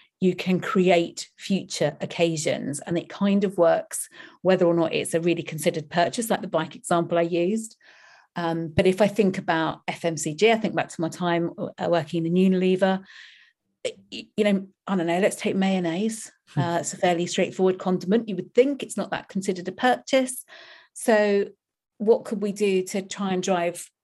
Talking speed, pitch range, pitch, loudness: 180 wpm, 170-205 Hz, 185 Hz, -24 LUFS